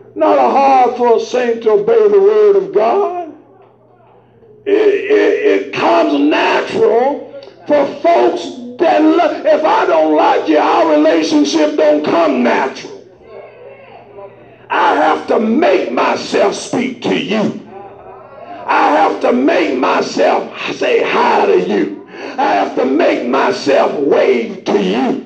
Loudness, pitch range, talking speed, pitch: -12 LUFS, 290-415 Hz, 135 wpm, 330 Hz